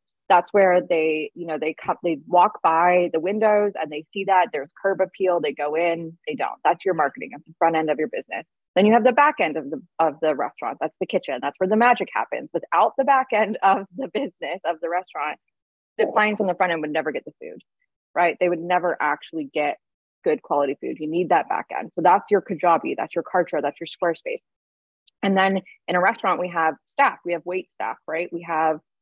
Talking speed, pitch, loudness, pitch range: 235 wpm, 175 Hz, -22 LUFS, 160-195 Hz